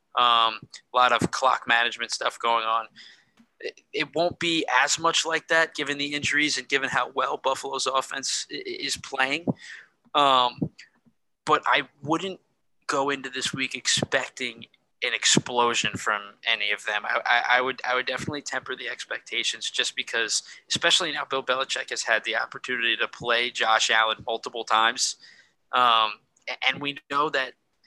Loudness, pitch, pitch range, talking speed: -24 LUFS, 130 Hz, 115-145 Hz, 160 wpm